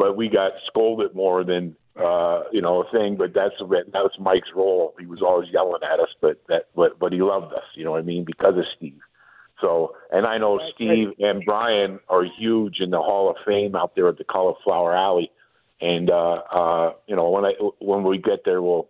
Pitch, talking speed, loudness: 105 Hz, 220 wpm, -22 LUFS